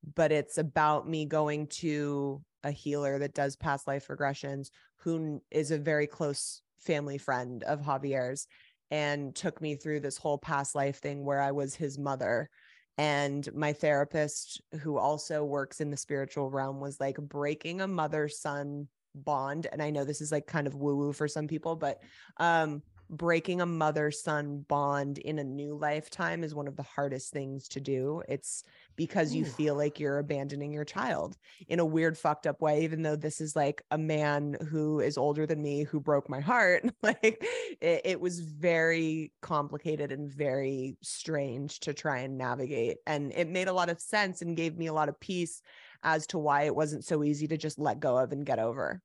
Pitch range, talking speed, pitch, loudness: 140-160 Hz, 195 wpm, 150 Hz, -32 LUFS